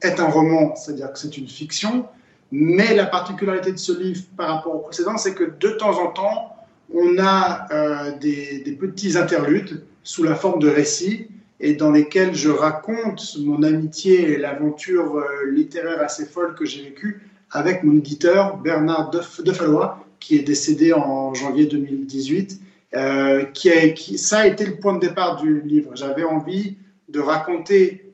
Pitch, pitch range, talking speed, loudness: 170 Hz, 150-190 Hz, 175 wpm, -19 LUFS